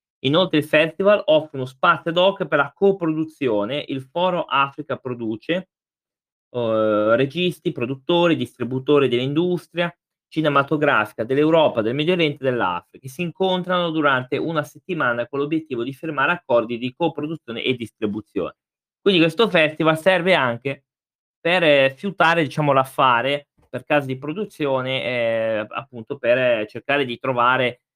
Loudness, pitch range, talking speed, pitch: -20 LUFS, 130-170 Hz, 130 wpm, 150 Hz